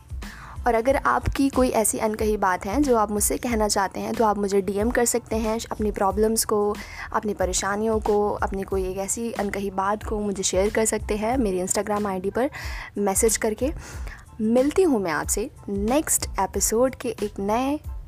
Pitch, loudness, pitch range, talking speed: 215 Hz, -23 LUFS, 200-230 Hz, 180 wpm